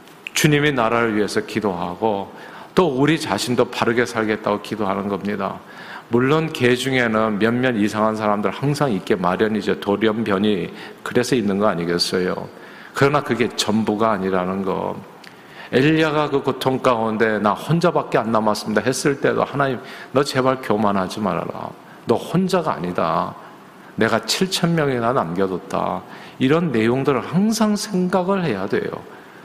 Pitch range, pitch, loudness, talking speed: 105-140 Hz, 115 Hz, -20 LUFS, 310 characters per minute